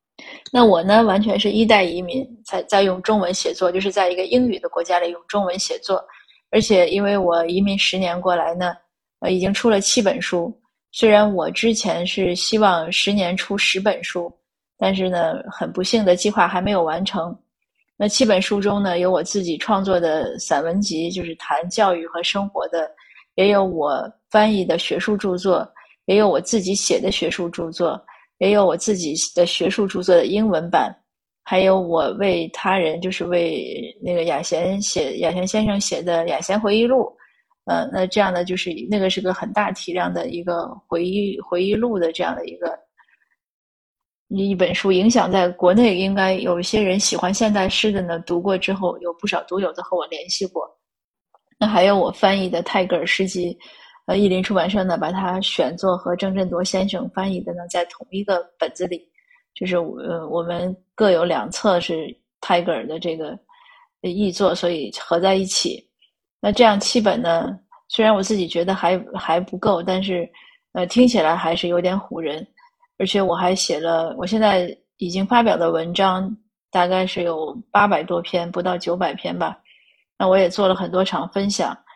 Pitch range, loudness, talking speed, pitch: 175-205 Hz, -20 LUFS, 265 characters per minute, 185 Hz